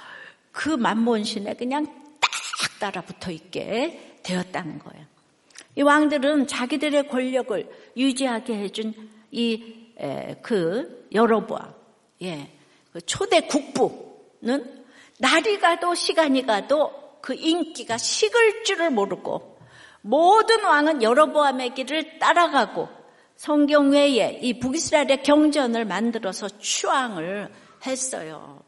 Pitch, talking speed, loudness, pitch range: 265 Hz, 230 characters per minute, -22 LUFS, 220-300 Hz